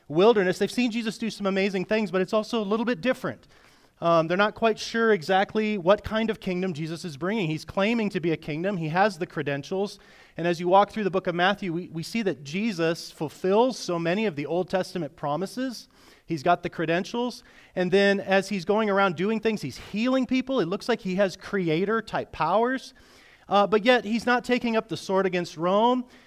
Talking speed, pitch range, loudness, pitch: 215 wpm, 175-220 Hz, -25 LUFS, 195 Hz